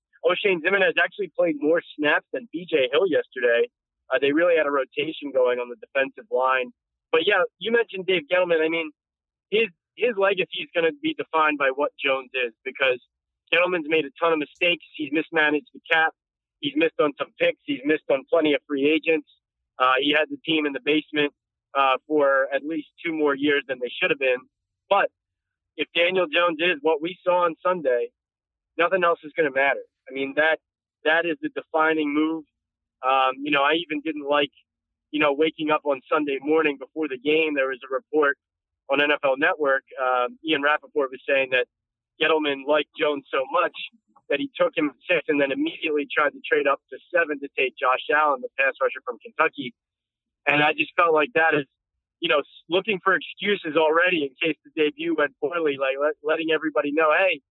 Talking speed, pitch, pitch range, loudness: 200 wpm, 155 Hz, 140-180 Hz, -23 LUFS